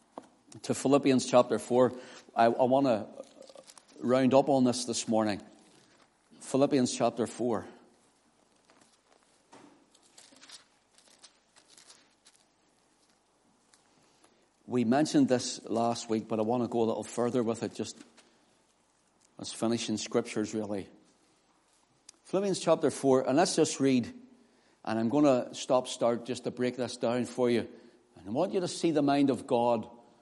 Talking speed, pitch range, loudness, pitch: 135 wpm, 115-135 Hz, -29 LUFS, 125 Hz